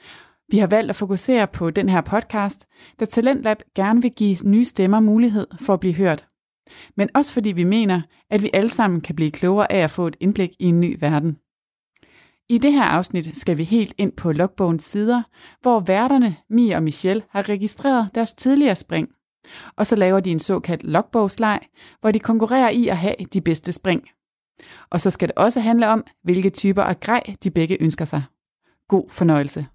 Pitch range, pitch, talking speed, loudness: 180-225 Hz, 200 Hz, 195 wpm, -19 LUFS